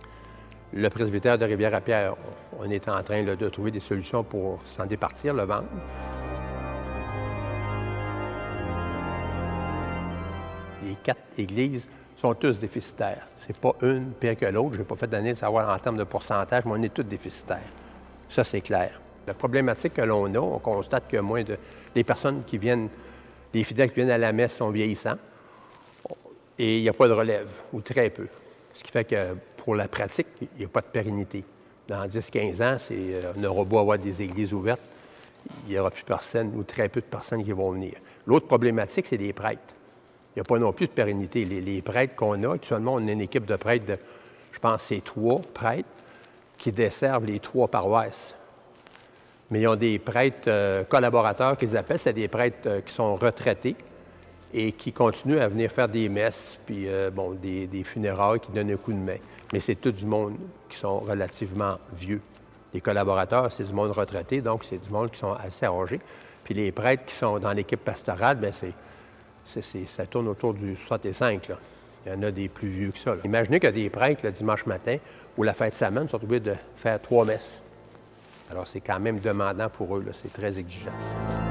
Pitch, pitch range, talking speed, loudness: 105 Hz, 100-115 Hz, 195 wpm, -27 LUFS